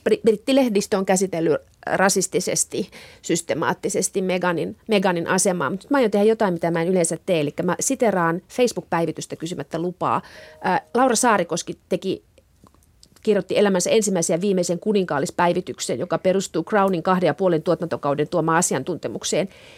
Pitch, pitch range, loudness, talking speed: 185 Hz, 170-205 Hz, -21 LUFS, 125 wpm